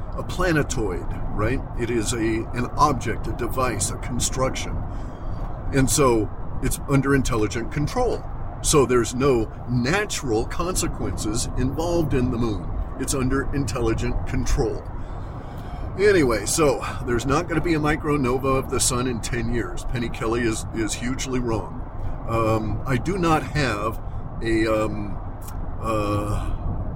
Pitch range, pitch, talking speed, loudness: 105-130 Hz, 115 Hz, 135 wpm, -24 LUFS